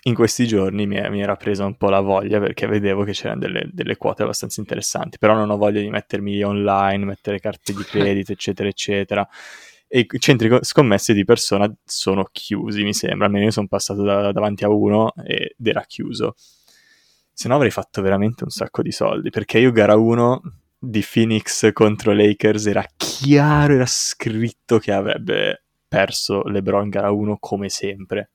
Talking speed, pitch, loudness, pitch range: 180 wpm, 105 Hz, -19 LUFS, 100-110 Hz